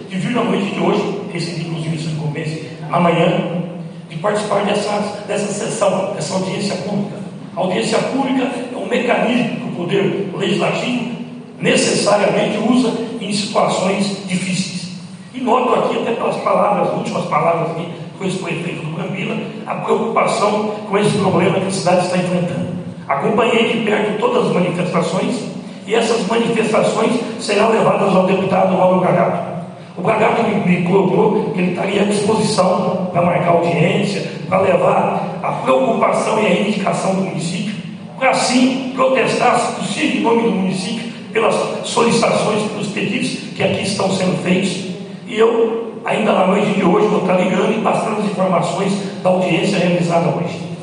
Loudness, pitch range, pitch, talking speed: -17 LUFS, 180-215 Hz, 195 Hz, 150 wpm